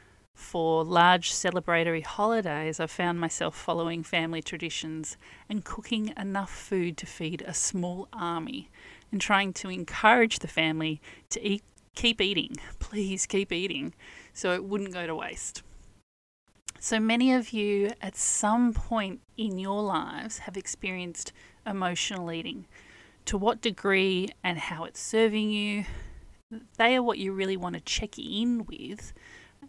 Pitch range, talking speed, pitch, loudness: 170-215 Hz, 140 wpm, 190 Hz, -28 LUFS